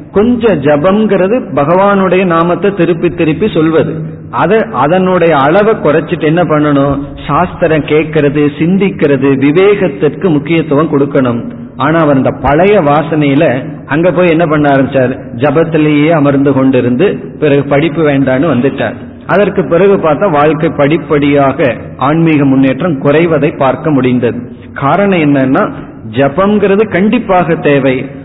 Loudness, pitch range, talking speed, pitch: -9 LUFS, 140-175 Hz, 105 wpm, 150 Hz